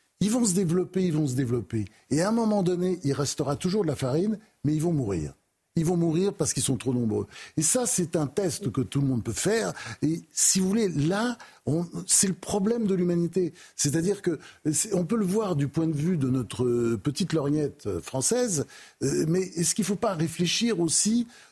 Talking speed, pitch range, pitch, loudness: 210 wpm, 140-195 Hz, 170 Hz, -26 LUFS